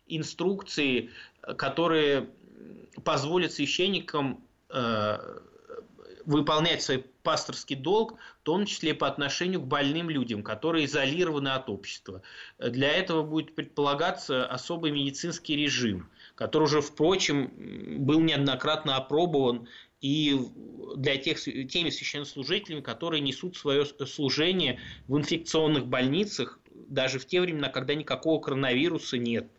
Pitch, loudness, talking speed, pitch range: 150 Hz, -28 LUFS, 110 wpm, 135-165 Hz